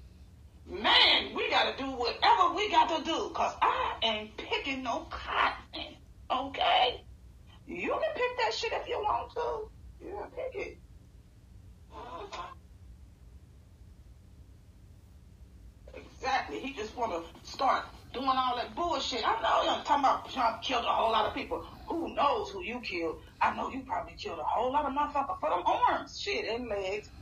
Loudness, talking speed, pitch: -30 LUFS, 155 wpm, 250 Hz